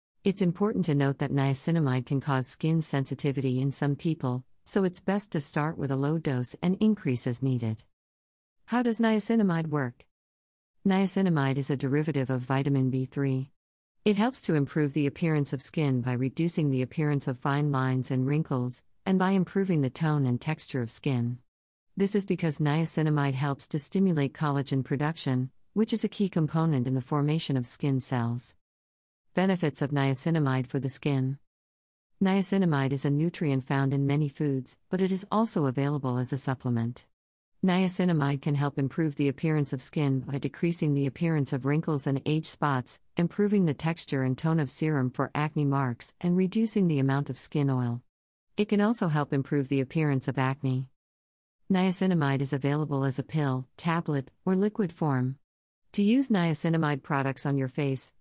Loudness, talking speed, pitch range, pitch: -28 LUFS, 170 wpm, 130-165 Hz, 145 Hz